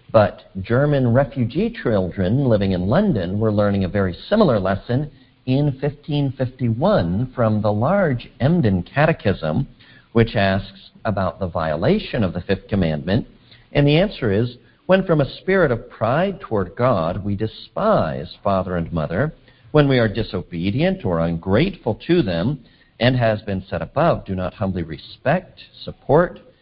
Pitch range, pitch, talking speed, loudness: 95-140 Hz, 115 Hz, 145 wpm, -20 LUFS